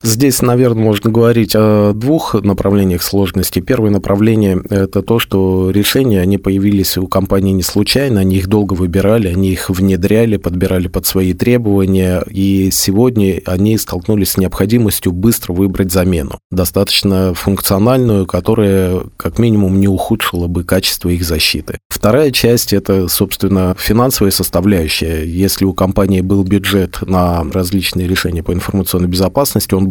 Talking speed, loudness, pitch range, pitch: 140 wpm, -12 LUFS, 95-105 Hz, 95 Hz